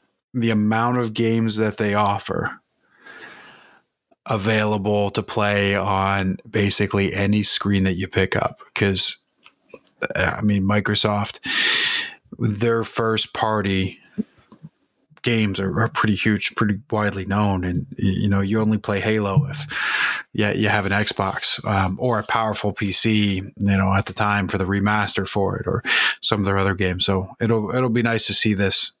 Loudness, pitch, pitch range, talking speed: -20 LUFS, 105 Hz, 100-110 Hz, 150 wpm